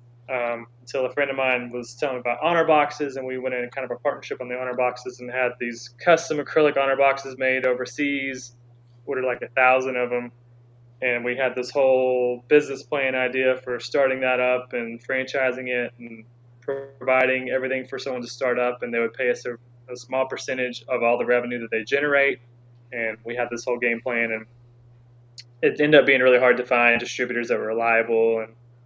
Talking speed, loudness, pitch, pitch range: 205 wpm, -23 LUFS, 125 Hz, 120-130 Hz